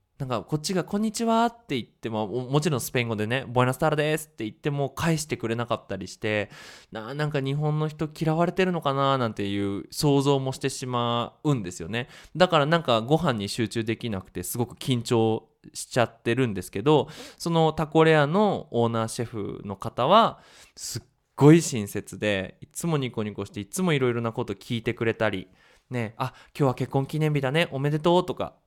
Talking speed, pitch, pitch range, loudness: 400 characters per minute, 130 Hz, 115-155 Hz, -25 LUFS